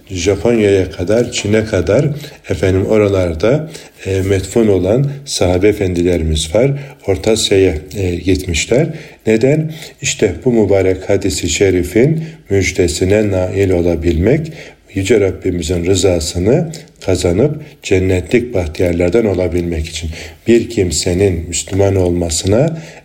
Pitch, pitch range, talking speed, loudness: 95 Hz, 90-115 Hz, 95 wpm, -14 LUFS